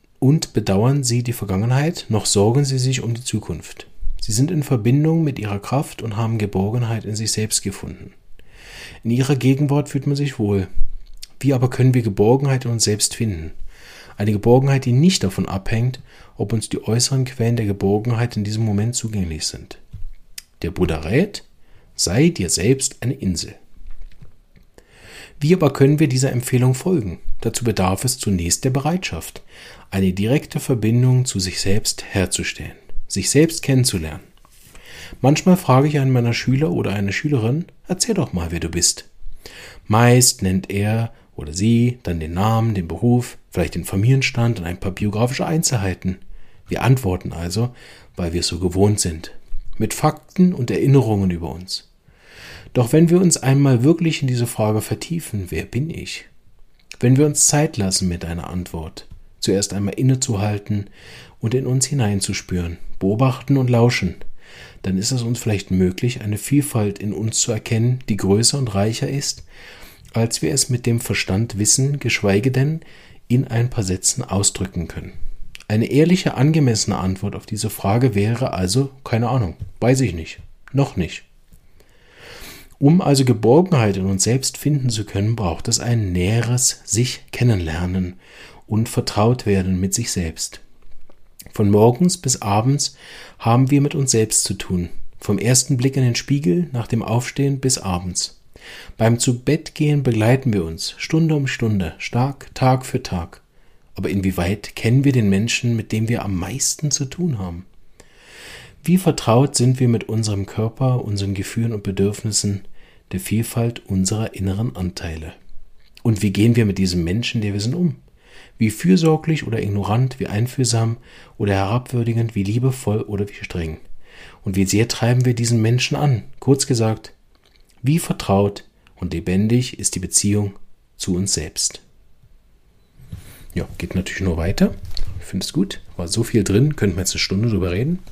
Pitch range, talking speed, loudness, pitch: 95-130 Hz, 160 wpm, -19 LUFS, 110 Hz